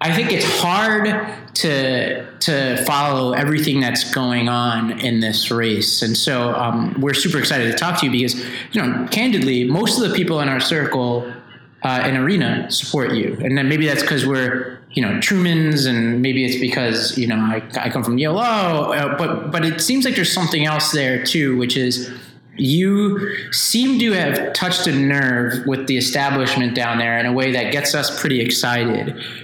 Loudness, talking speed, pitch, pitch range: -18 LUFS, 190 wpm, 130 Hz, 125-155 Hz